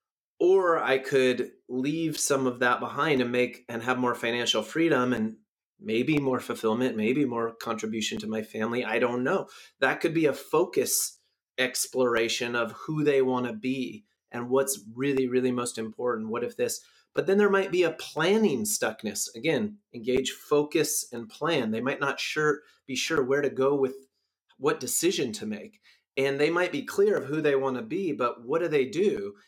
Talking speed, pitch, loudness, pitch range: 185 wpm, 130 Hz, -27 LUFS, 120-155 Hz